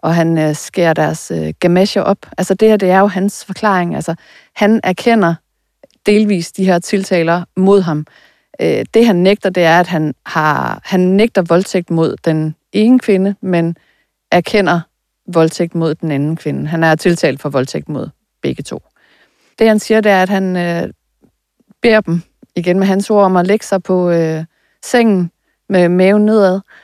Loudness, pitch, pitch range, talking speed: -13 LUFS, 185 Hz, 165-200 Hz, 170 wpm